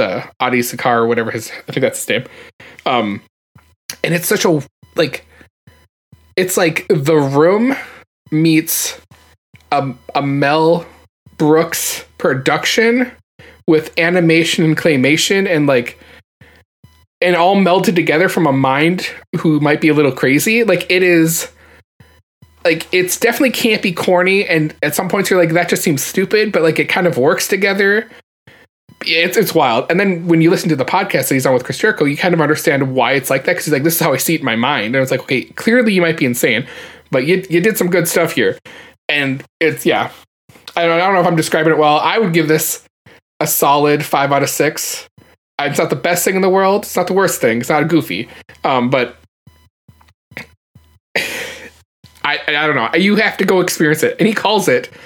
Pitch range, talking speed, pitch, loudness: 150-190 Hz, 200 wpm, 165 Hz, -14 LUFS